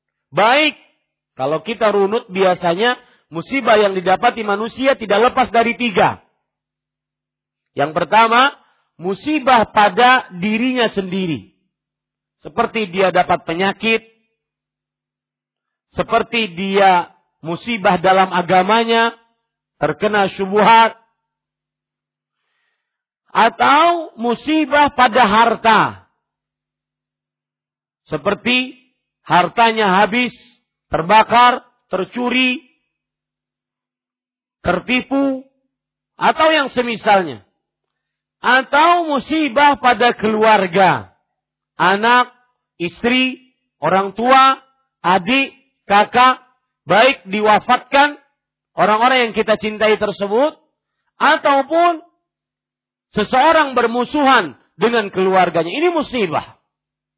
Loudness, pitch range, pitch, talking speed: -15 LUFS, 195-255 Hz, 230 Hz, 70 wpm